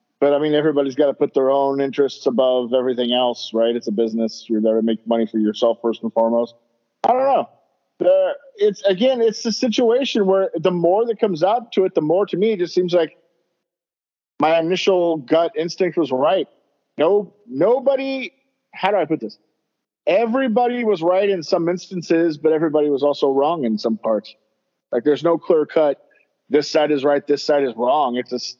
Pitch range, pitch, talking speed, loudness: 125-195 Hz, 160 Hz, 195 wpm, -19 LUFS